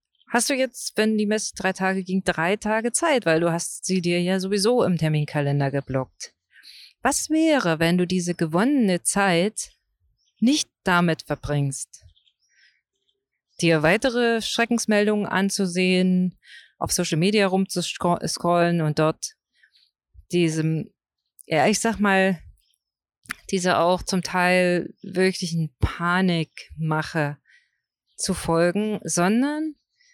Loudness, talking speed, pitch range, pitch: -22 LUFS, 110 wpm, 165-210 Hz, 180 Hz